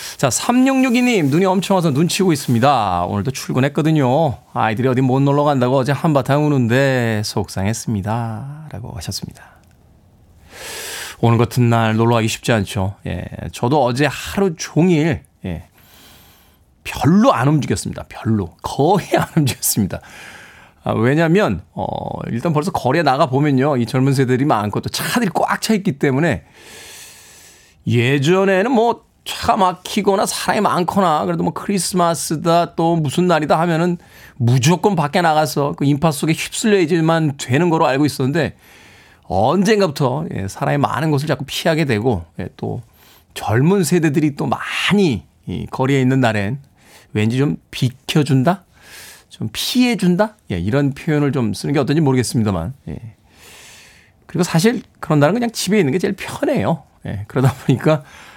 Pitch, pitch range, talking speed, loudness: 145 Hz, 115-170 Hz, 310 characters per minute, -17 LUFS